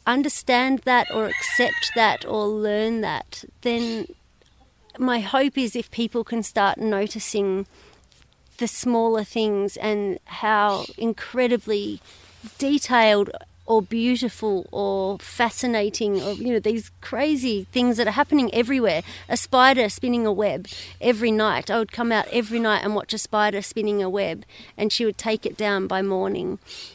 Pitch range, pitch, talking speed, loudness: 210-245 Hz, 220 Hz, 145 wpm, -22 LUFS